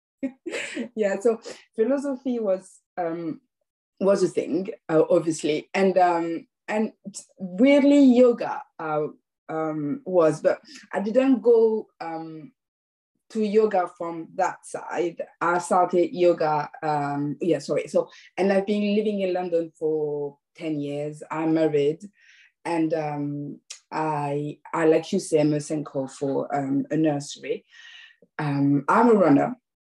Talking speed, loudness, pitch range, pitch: 125 wpm, -24 LUFS, 150-220 Hz, 175 Hz